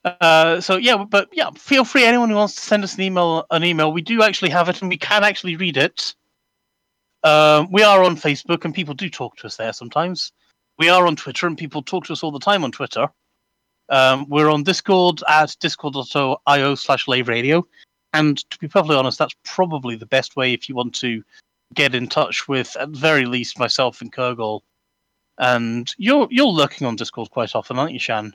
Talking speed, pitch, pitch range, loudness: 210 wpm, 155 Hz, 130-185 Hz, -18 LUFS